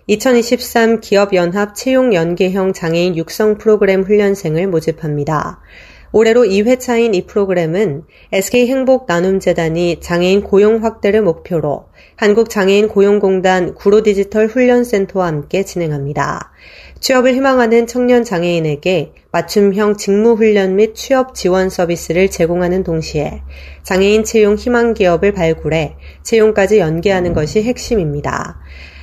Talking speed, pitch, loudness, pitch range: 310 characters per minute, 195 Hz, -13 LUFS, 170-220 Hz